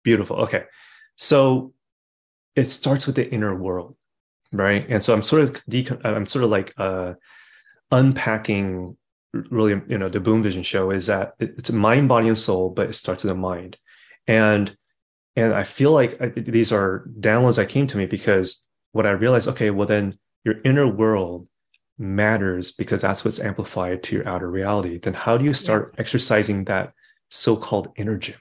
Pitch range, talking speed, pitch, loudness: 95-125 Hz, 180 wpm, 105 Hz, -21 LUFS